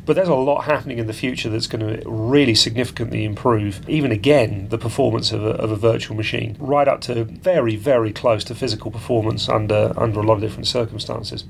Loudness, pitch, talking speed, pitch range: -20 LUFS, 115 Hz, 210 wpm, 110-125 Hz